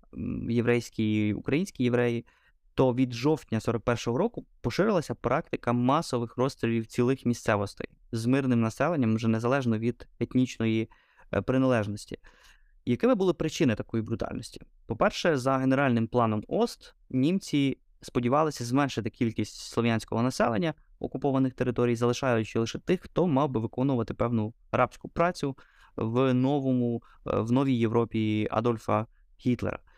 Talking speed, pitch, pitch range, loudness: 115 wpm, 120 Hz, 115-135 Hz, -28 LUFS